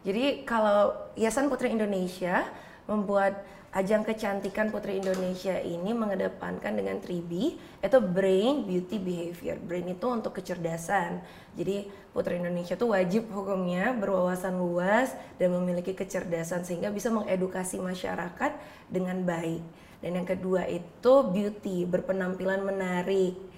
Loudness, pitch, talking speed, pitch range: -29 LUFS, 190 Hz, 115 wpm, 180-205 Hz